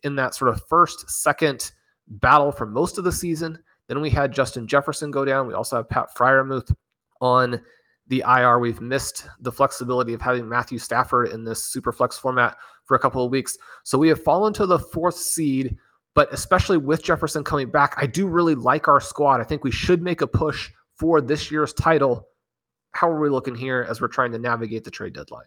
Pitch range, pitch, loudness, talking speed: 125-150 Hz, 135 Hz, -21 LUFS, 210 wpm